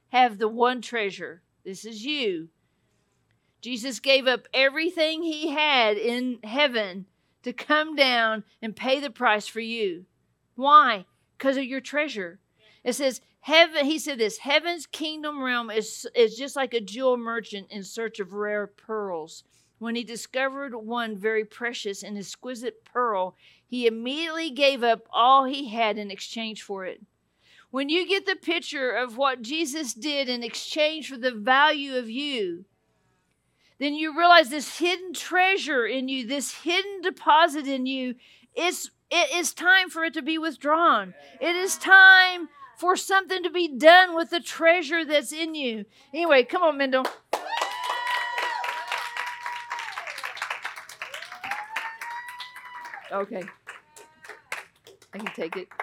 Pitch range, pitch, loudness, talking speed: 225-325 Hz, 270 Hz, -24 LUFS, 140 wpm